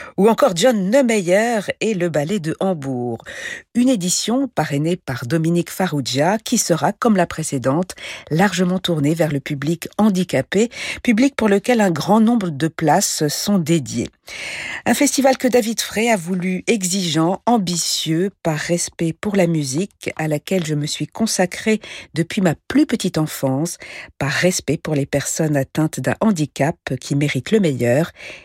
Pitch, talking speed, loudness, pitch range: 175 Hz, 155 wpm, -19 LUFS, 150-210 Hz